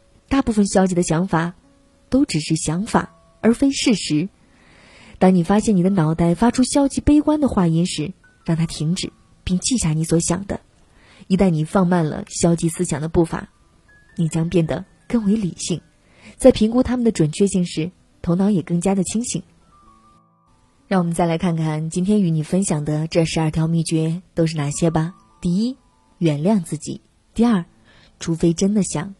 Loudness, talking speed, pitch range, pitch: -19 LUFS, 255 characters per minute, 165-200 Hz, 180 Hz